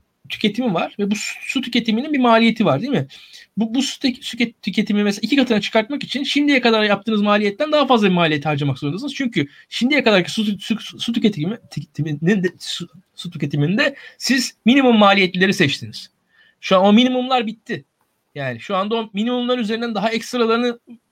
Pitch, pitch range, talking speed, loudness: 220 Hz, 190-245 Hz, 170 wpm, -18 LUFS